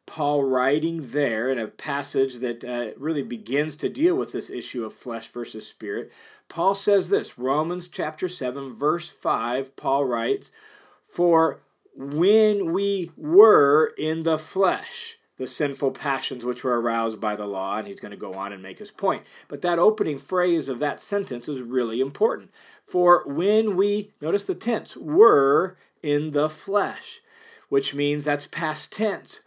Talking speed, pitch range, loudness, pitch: 165 wpm, 135-215 Hz, -23 LUFS, 155 Hz